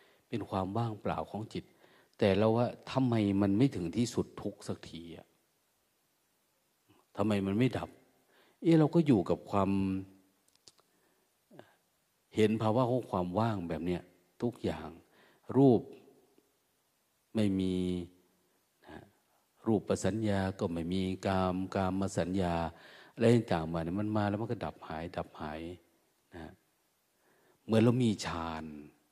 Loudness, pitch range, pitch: -32 LUFS, 90-110 Hz, 95 Hz